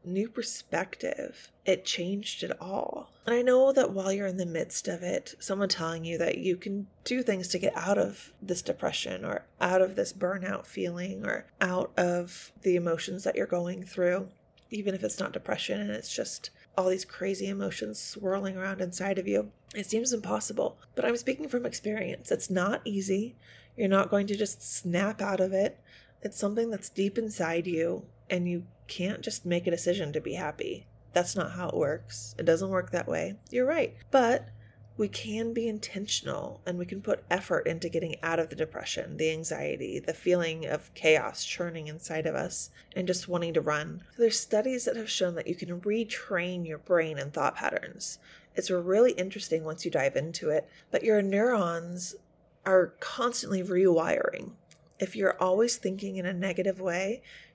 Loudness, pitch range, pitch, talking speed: -30 LUFS, 170-205 Hz, 185 Hz, 185 wpm